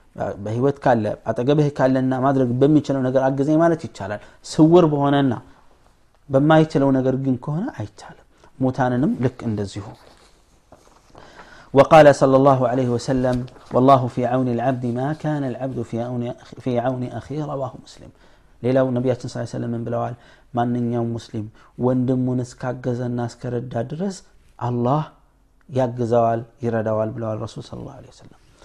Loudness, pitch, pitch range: -20 LUFS, 125 Hz, 120-140 Hz